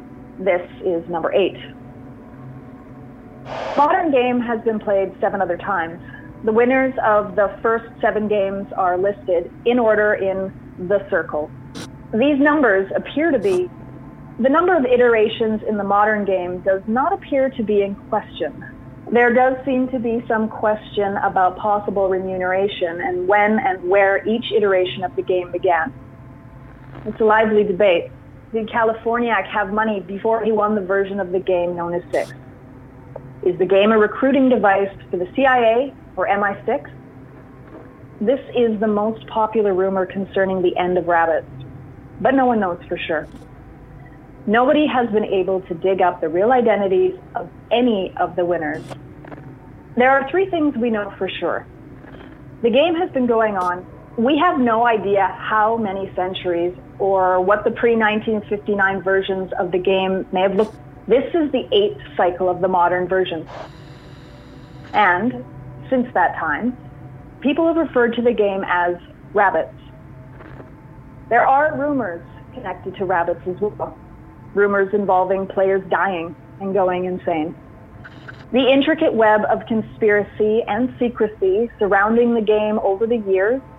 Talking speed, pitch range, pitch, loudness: 150 wpm, 180-230 Hz, 200 Hz, -19 LUFS